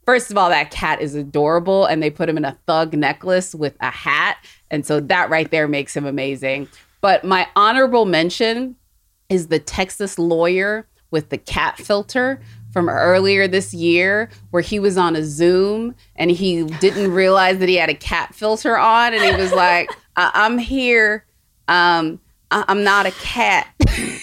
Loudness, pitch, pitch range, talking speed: -17 LUFS, 180 Hz, 160-205 Hz, 180 wpm